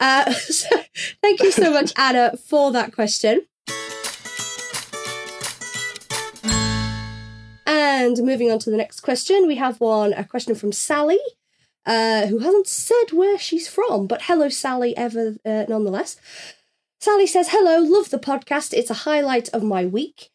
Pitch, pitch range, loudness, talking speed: 255 Hz, 215-330 Hz, -20 LUFS, 145 wpm